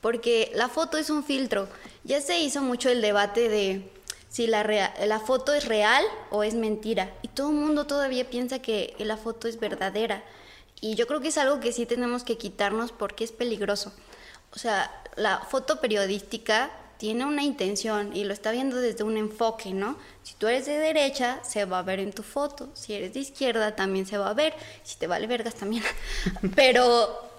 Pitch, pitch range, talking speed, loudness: 230 Hz, 210-260 Hz, 200 wpm, -27 LUFS